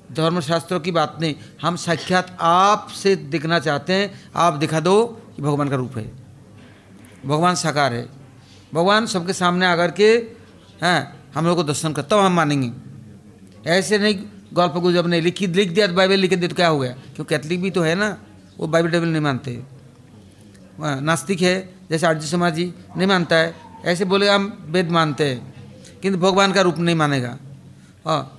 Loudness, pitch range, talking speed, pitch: -19 LUFS, 145-185 Hz, 180 wpm, 170 Hz